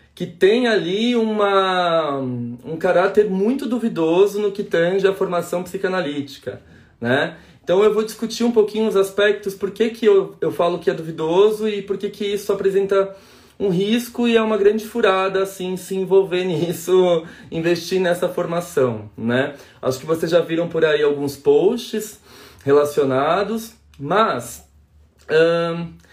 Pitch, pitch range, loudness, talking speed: 190 Hz, 165-205 Hz, -19 LUFS, 150 wpm